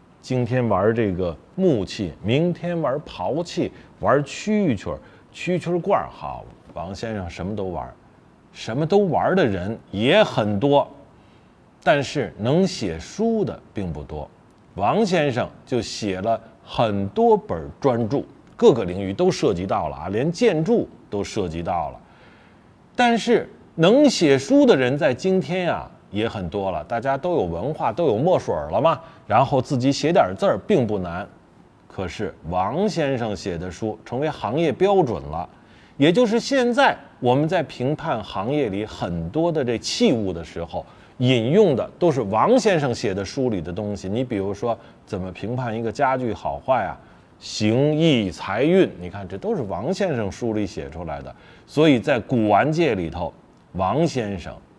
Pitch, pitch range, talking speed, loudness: 120 Hz, 100-160 Hz, 230 characters per minute, -22 LUFS